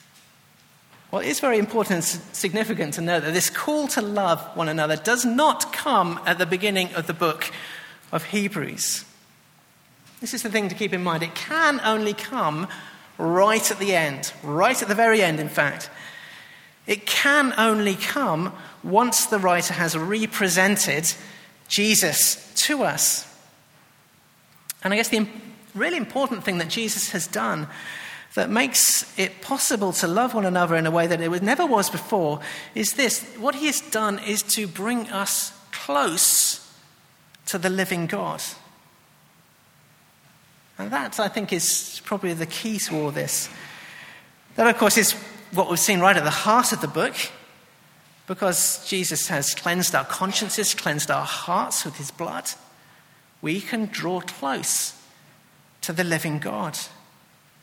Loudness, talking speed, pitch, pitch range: -22 LUFS, 155 wpm, 195 Hz, 170-220 Hz